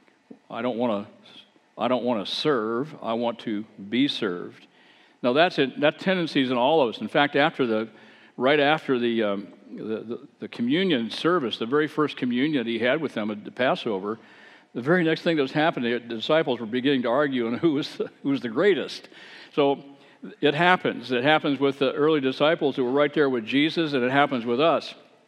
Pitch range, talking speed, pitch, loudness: 120-155 Hz, 195 wpm, 140 Hz, -24 LUFS